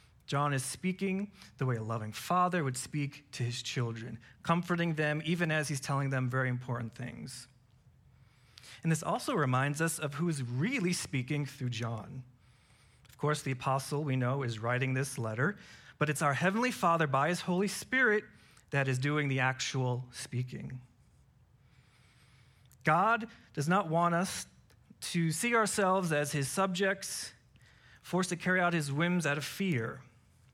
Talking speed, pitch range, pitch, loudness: 155 wpm, 125-170 Hz, 135 Hz, -32 LUFS